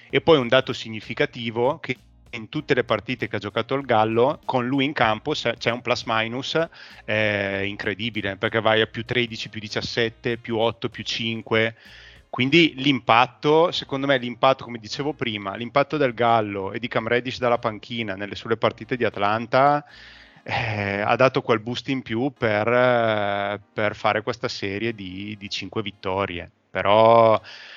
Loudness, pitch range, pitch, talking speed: -22 LUFS, 110-130 Hz, 115 Hz, 160 wpm